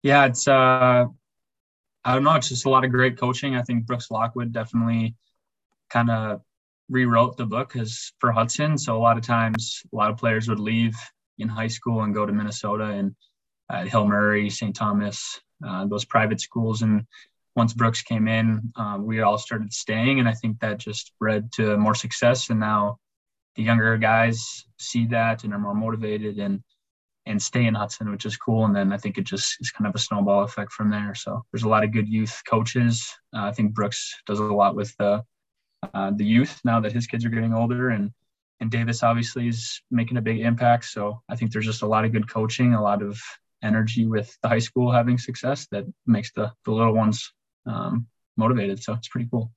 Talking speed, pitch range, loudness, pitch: 210 wpm, 105-120 Hz, -23 LUFS, 115 Hz